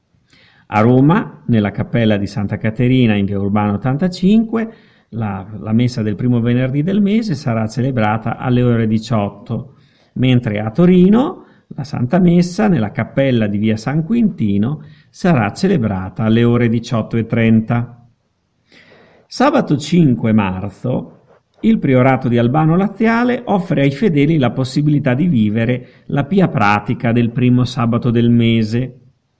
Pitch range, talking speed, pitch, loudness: 110-155 Hz, 130 wpm, 125 Hz, -15 LUFS